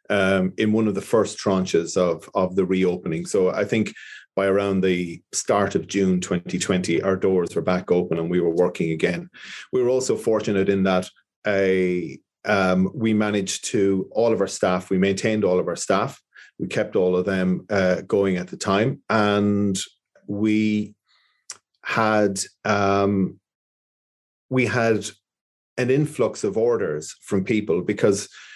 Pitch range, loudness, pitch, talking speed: 90-105 Hz, -22 LUFS, 95 Hz, 160 wpm